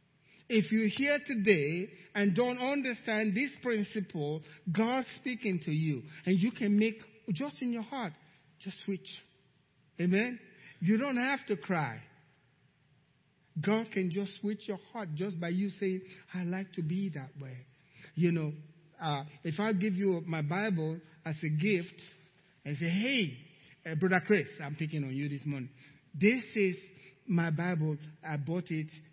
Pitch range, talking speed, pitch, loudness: 155-210 Hz, 155 wpm, 180 Hz, -33 LUFS